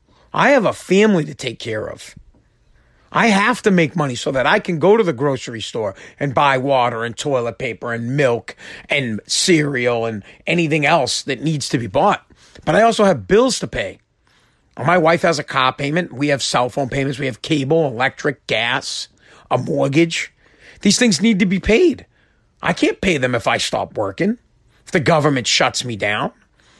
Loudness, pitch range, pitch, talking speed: -17 LUFS, 125-180 Hz, 145 Hz, 190 wpm